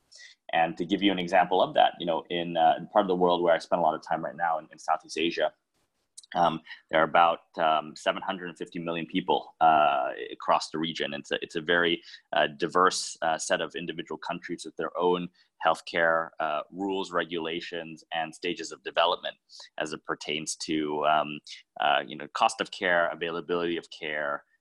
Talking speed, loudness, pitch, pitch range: 195 wpm, -28 LUFS, 85 Hz, 80-90 Hz